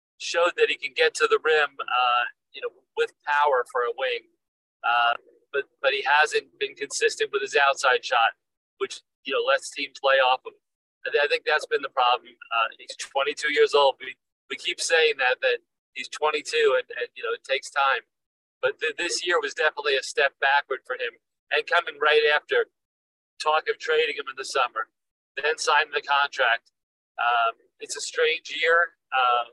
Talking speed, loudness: 190 wpm, -24 LUFS